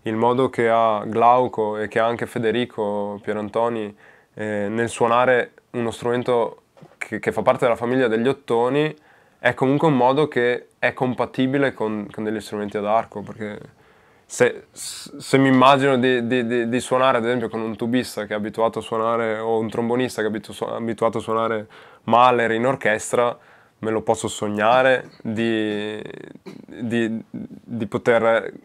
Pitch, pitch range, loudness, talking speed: 115 Hz, 110-125 Hz, -21 LUFS, 160 wpm